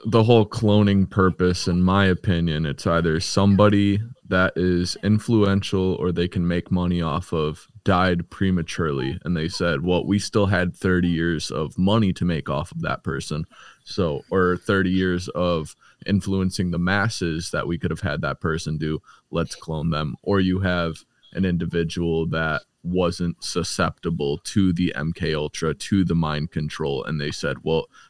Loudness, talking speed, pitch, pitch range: -22 LUFS, 165 wpm, 90 Hz, 80-95 Hz